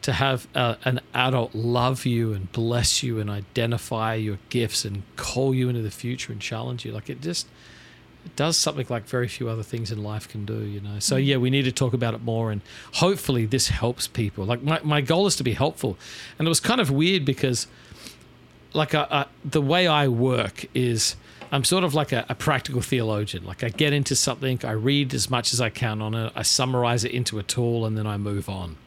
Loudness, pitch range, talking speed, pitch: -24 LUFS, 110-135 Hz, 230 wpm, 125 Hz